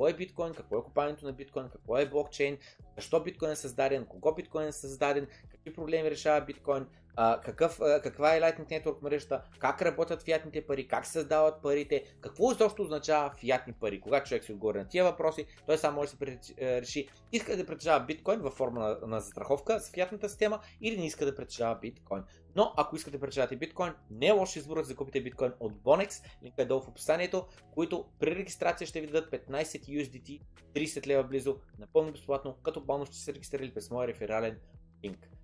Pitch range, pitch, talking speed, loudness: 130-160 Hz, 145 Hz, 200 wpm, -32 LUFS